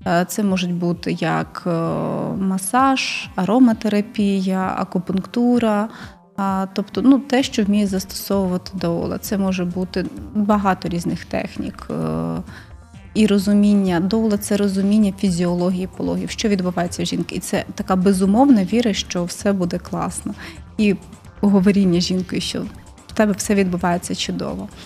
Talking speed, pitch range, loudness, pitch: 120 wpm, 180-210 Hz, -19 LUFS, 195 Hz